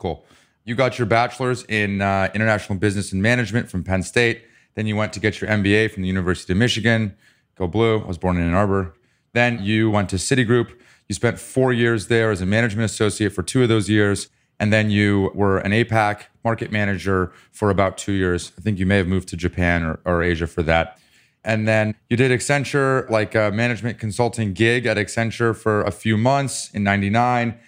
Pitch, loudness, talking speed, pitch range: 105 Hz, -20 LUFS, 210 wpm, 95-115 Hz